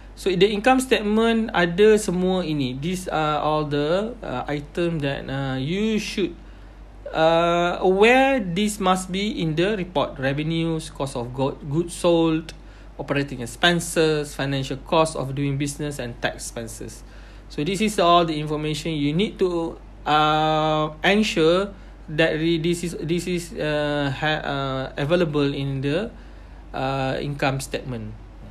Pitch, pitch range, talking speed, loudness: 155 Hz, 140-180 Hz, 140 wpm, -22 LUFS